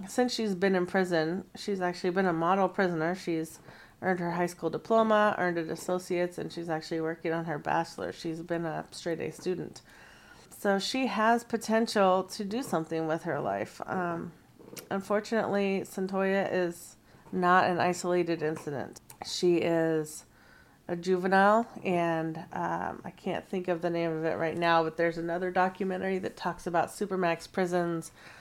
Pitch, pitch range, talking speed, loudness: 180 Hz, 165-195 Hz, 160 wpm, -30 LUFS